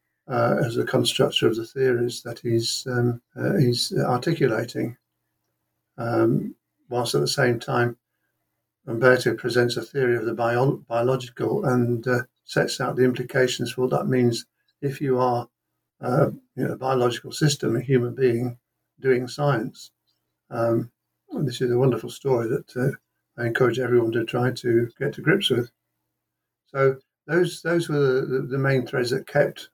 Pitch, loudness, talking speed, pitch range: 125 Hz, -23 LUFS, 160 wpm, 120-130 Hz